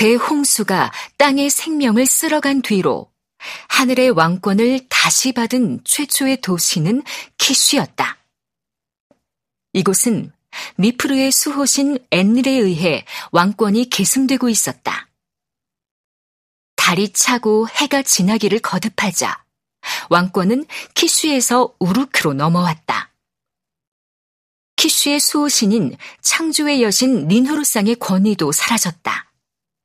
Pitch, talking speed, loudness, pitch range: 235 Hz, 225 characters per minute, -15 LUFS, 195-275 Hz